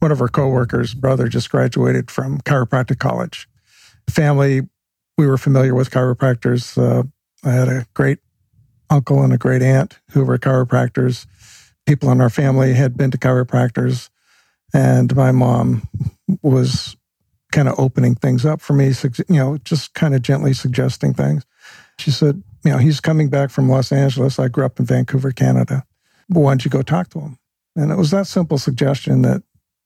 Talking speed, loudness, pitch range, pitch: 175 wpm, -16 LUFS, 125-145 Hz, 130 Hz